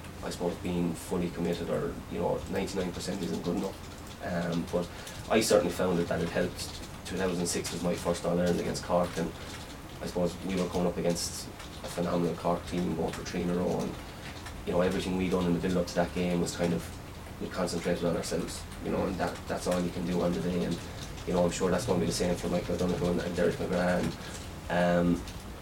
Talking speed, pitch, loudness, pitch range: 215 wpm, 85 Hz, -31 LUFS, 85-90 Hz